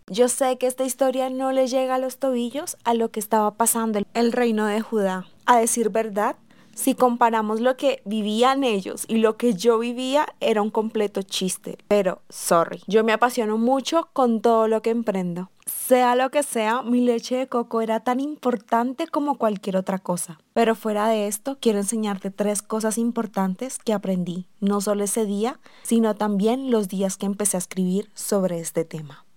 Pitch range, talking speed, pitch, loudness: 205-250 Hz, 185 wpm, 225 Hz, -23 LUFS